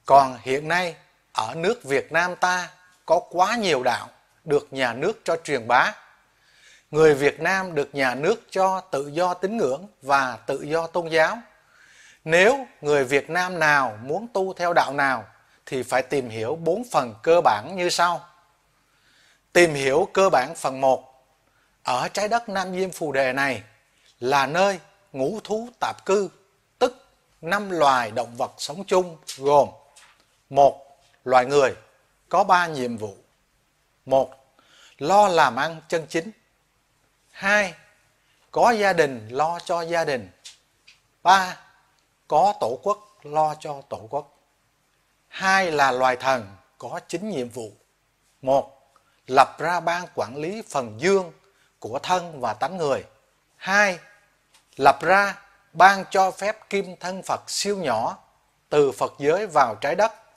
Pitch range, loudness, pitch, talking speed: 135-190 Hz, -22 LUFS, 165 Hz, 150 wpm